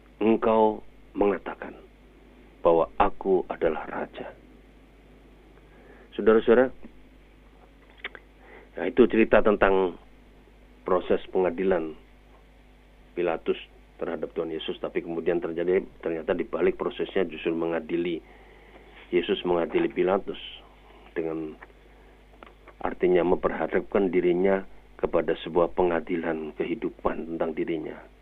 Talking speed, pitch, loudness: 85 wpm, 110 Hz, -26 LUFS